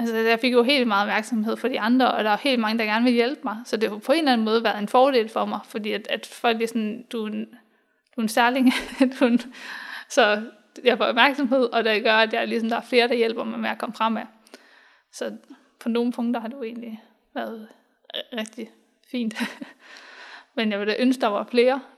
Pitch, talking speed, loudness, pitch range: 235 Hz, 240 wpm, -22 LUFS, 225-255 Hz